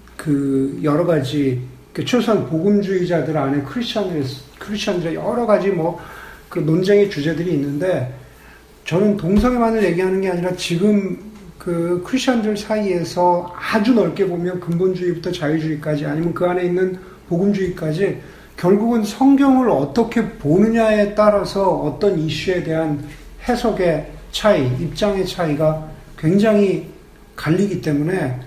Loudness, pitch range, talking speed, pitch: -18 LUFS, 155-205 Hz, 305 characters per minute, 180 Hz